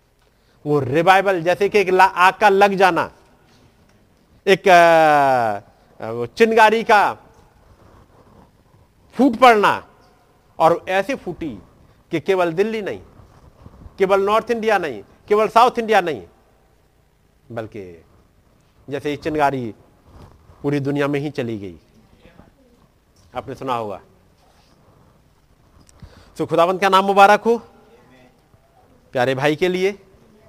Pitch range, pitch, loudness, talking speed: 135-200 Hz, 170 Hz, -17 LUFS, 110 wpm